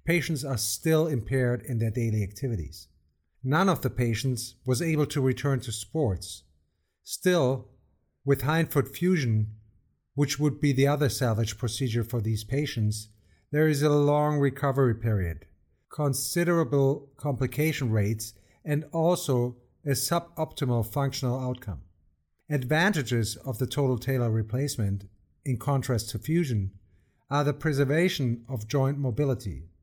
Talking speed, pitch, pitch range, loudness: 125 wpm, 130 Hz, 110-145 Hz, -27 LUFS